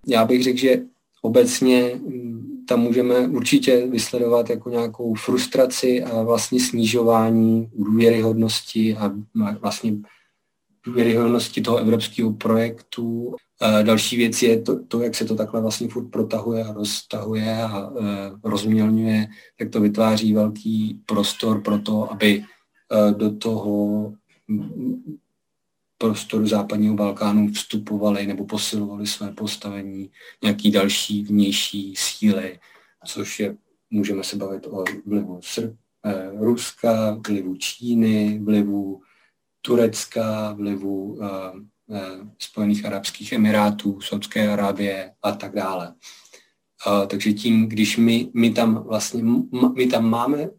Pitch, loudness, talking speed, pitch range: 110 Hz, -21 LUFS, 115 wpm, 105-115 Hz